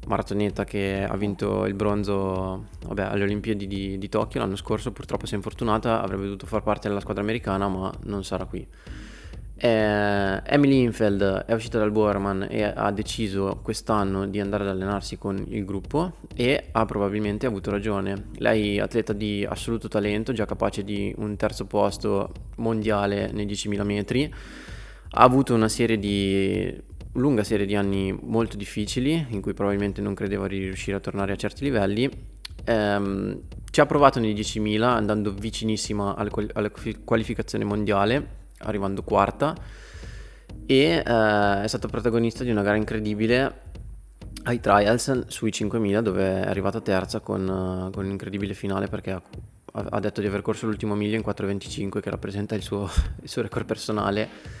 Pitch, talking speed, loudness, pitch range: 105 Hz, 165 wpm, -25 LUFS, 100-110 Hz